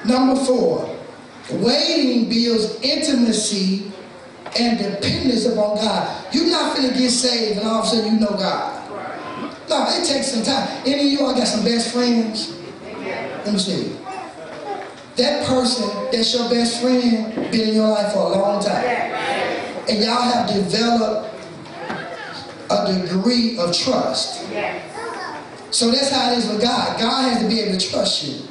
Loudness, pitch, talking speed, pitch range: -19 LUFS, 235 Hz, 155 wpm, 215-255 Hz